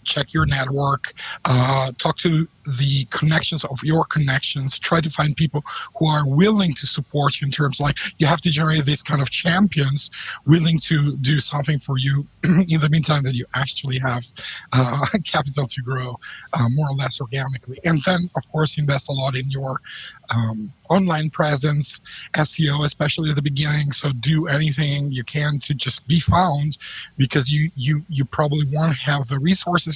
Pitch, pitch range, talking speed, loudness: 145 Hz, 135-155 Hz, 180 wpm, -20 LUFS